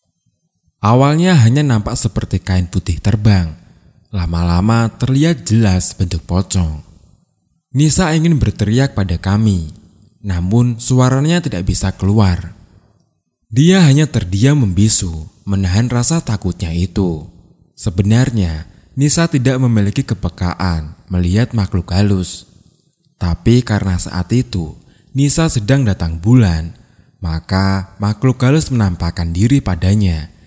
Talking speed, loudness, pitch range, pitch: 100 wpm, -14 LUFS, 90-125 Hz, 105 Hz